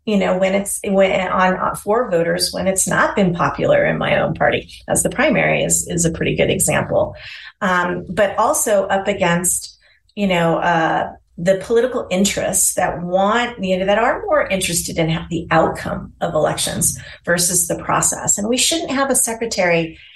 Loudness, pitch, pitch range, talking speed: -17 LUFS, 190 Hz, 175-210 Hz, 180 wpm